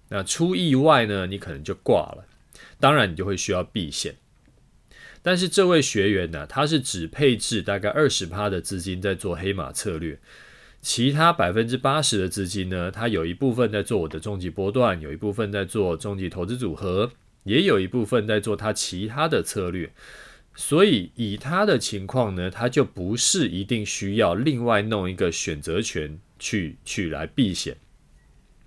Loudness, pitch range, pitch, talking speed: -23 LUFS, 95-125 Hz, 105 Hz, 260 characters per minute